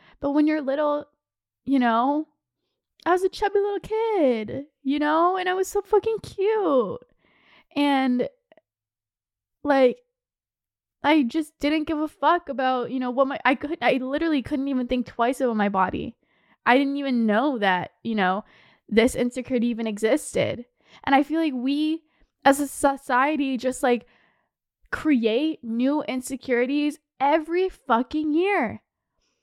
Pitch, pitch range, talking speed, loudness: 280 Hz, 250-310 Hz, 145 wpm, -24 LUFS